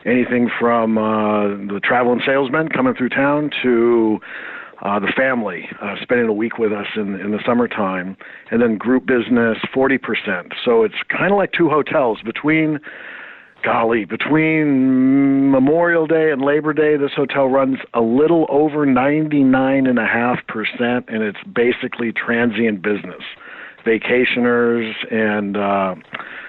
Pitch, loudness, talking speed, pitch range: 125 Hz, -17 LUFS, 135 wpm, 115-140 Hz